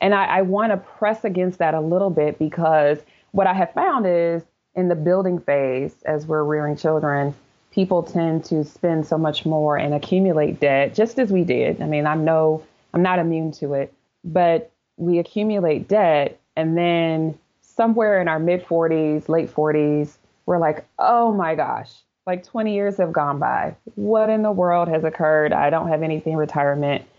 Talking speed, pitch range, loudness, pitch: 190 wpm, 155-185 Hz, -20 LUFS, 165 Hz